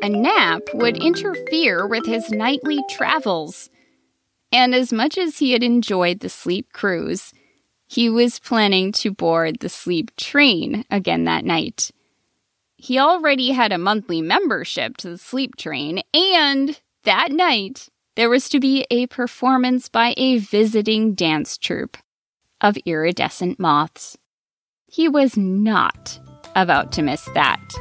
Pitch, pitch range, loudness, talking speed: 235 Hz, 190-270 Hz, -19 LUFS, 135 wpm